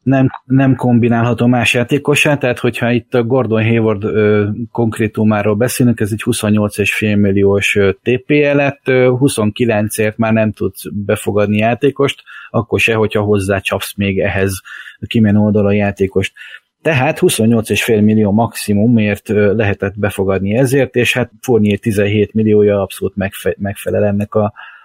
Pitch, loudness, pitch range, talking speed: 110 Hz, -14 LUFS, 105-120 Hz, 125 wpm